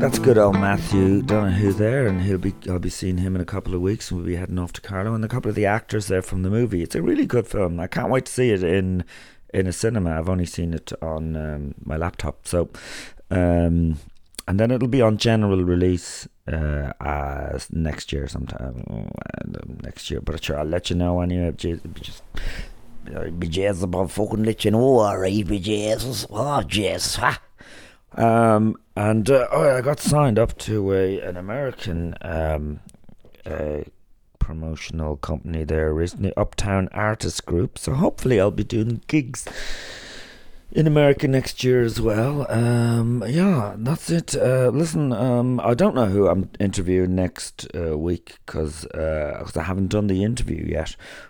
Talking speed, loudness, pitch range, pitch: 180 wpm, -22 LUFS, 85-110 Hz, 95 Hz